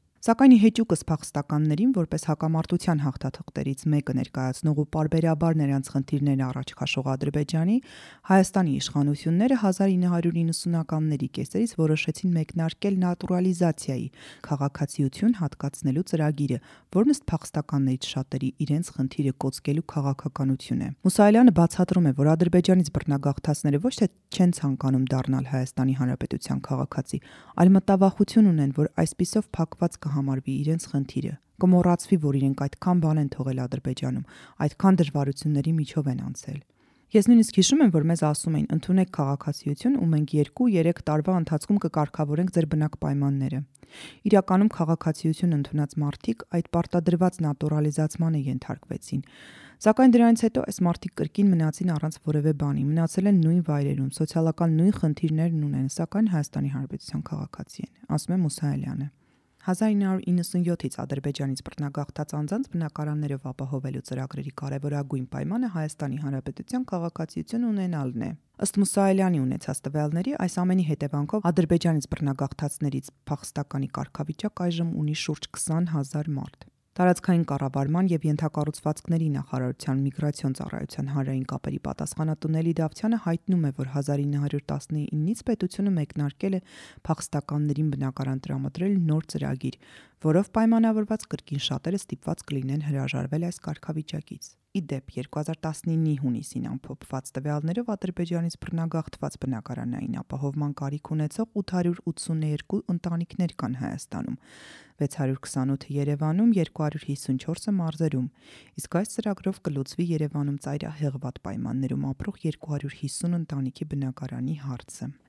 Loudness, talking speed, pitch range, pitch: -26 LUFS, 115 wpm, 140-175 Hz, 155 Hz